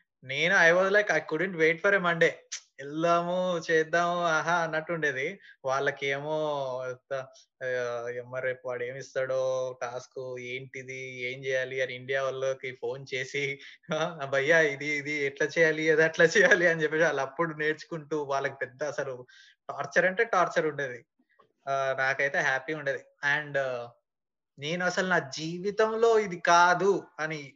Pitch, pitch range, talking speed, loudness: 145 Hz, 130-170 Hz, 135 wpm, -27 LUFS